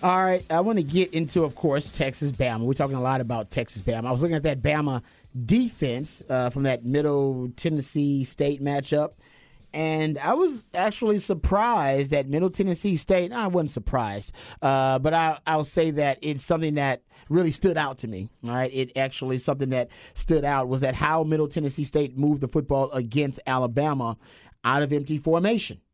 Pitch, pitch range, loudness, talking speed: 145 Hz, 130-160 Hz, -25 LUFS, 185 wpm